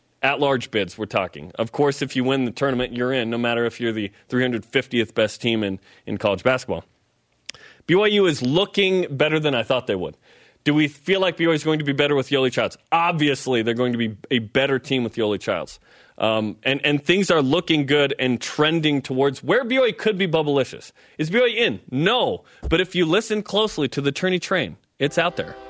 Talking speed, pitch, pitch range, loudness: 210 wpm, 140 Hz, 120-165 Hz, -21 LUFS